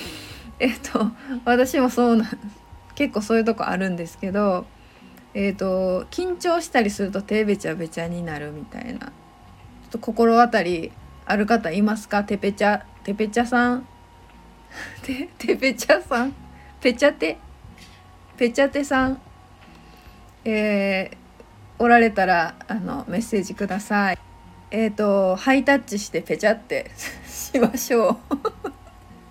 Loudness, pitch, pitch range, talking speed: -22 LUFS, 220 Hz, 195-250 Hz, 270 characters per minute